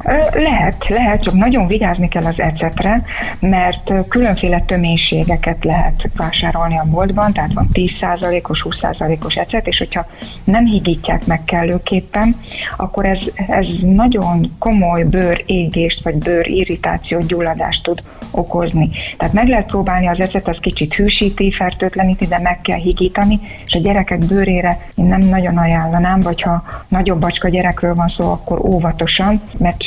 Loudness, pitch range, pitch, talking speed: -15 LUFS, 170-195 Hz, 180 Hz, 145 wpm